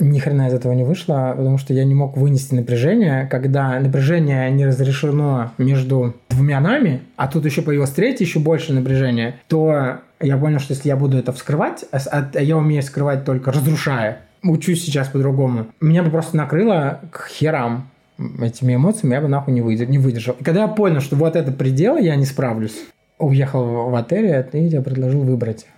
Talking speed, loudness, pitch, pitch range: 180 wpm, -18 LUFS, 140 Hz, 130-155 Hz